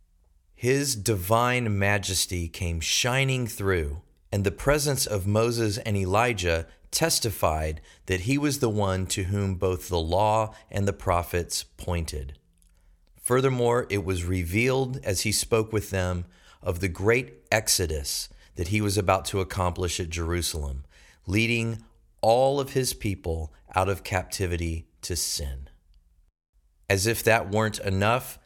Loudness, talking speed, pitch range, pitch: -26 LUFS, 135 wpm, 85-115 Hz, 95 Hz